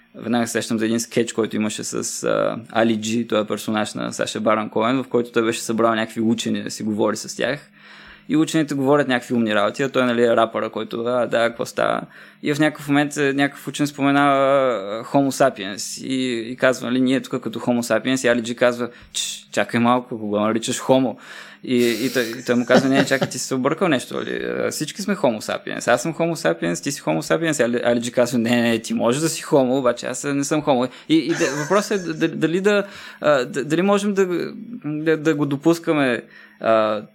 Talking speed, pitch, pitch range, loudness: 205 wpm, 125 Hz, 115-145 Hz, -20 LUFS